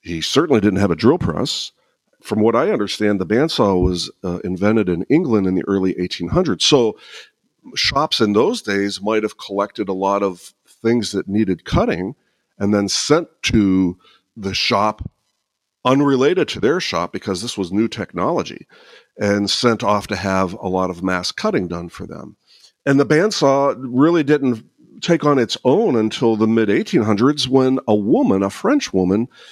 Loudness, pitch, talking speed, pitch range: -18 LUFS, 105 Hz, 170 wpm, 95-120 Hz